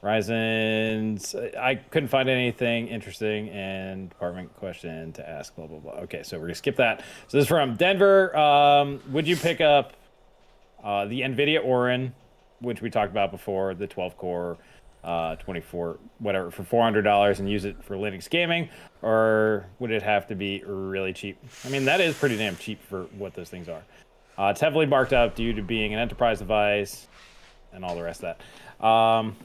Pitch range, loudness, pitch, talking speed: 100-130 Hz, -24 LUFS, 110 Hz, 190 wpm